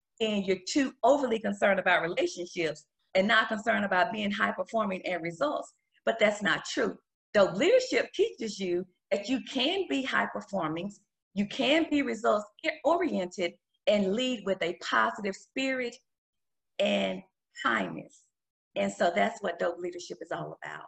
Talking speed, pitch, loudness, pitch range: 150 wpm, 205 Hz, -29 LUFS, 180-255 Hz